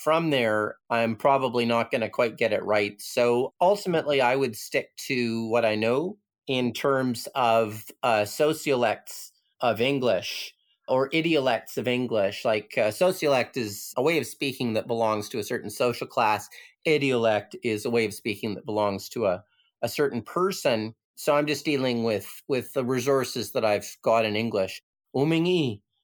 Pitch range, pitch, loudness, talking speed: 110-140 Hz, 120 Hz, -26 LUFS, 170 wpm